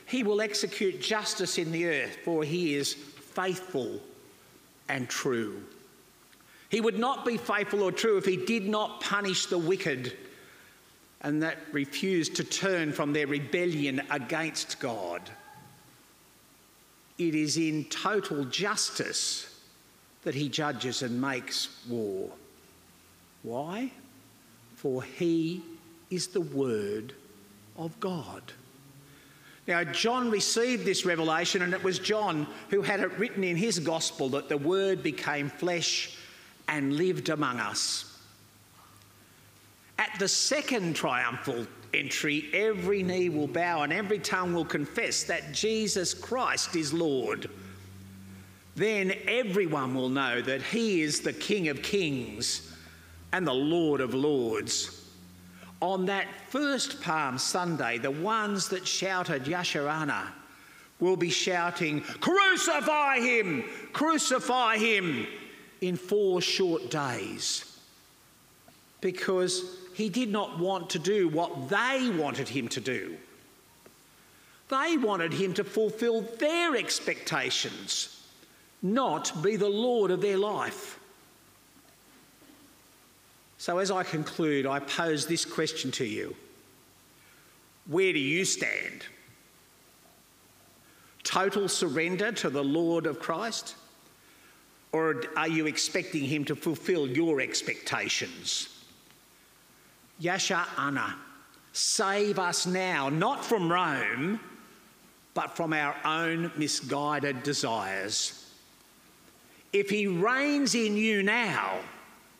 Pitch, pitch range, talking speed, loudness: 175 Hz, 145-205 Hz, 115 wpm, -29 LUFS